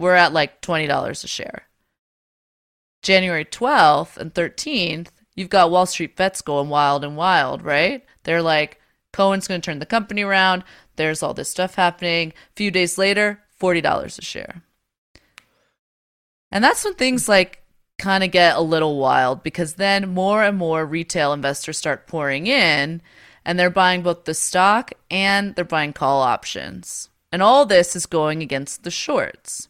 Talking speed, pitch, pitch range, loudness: 170 wpm, 175 Hz, 160-195 Hz, -19 LUFS